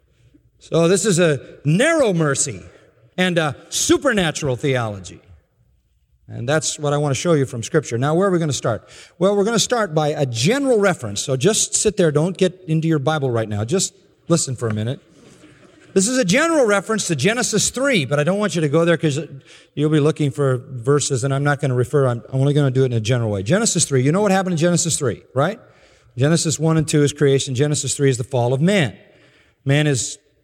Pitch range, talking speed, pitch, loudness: 135-180 Hz, 225 wpm, 150 Hz, -18 LUFS